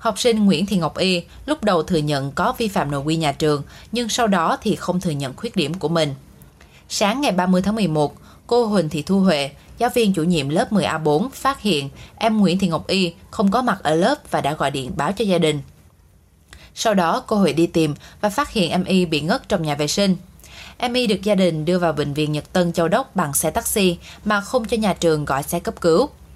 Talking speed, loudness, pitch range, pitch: 240 wpm, -20 LUFS, 150-210 Hz, 175 Hz